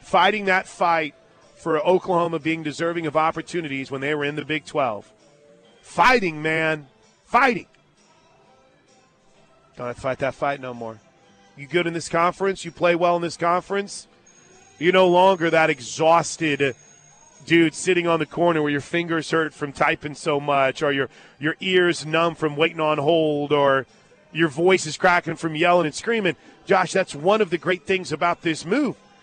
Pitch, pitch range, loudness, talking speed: 165 Hz, 150-175 Hz, -21 LUFS, 170 wpm